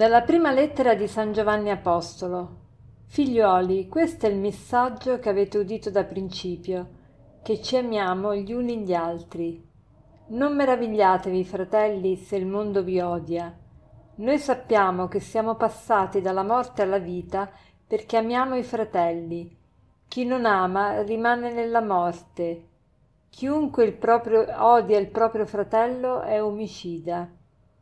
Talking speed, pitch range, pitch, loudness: 130 wpm, 180-230 Hz, 205 Hz, -24 LUFS